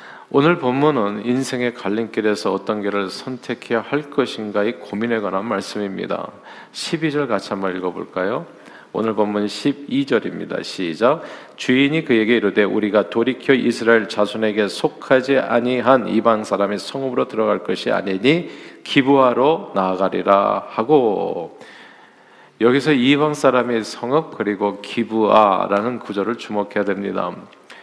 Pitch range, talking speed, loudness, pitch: 105-130 Hz, 305 characters per minute, -19 LUFS, 115 Hz